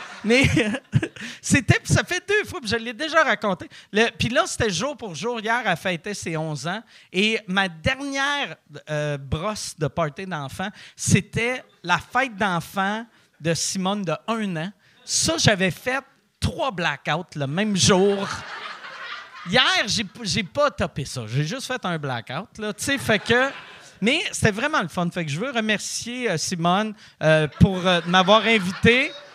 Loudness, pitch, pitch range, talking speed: -22 LUFS, 200 Hz, 170-235 Hz, 165 wpm